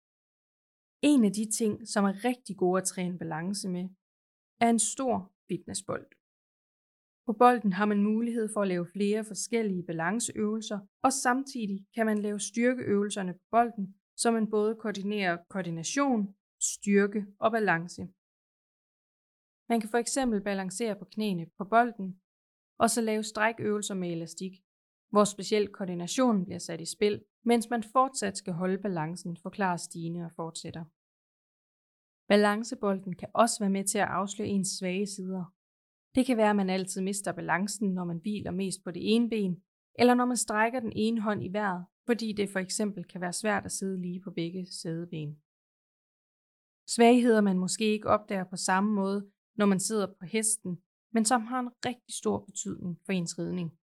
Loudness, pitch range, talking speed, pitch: -29 LUFS, 185-220 Hz, 165 wpm, 200 Hz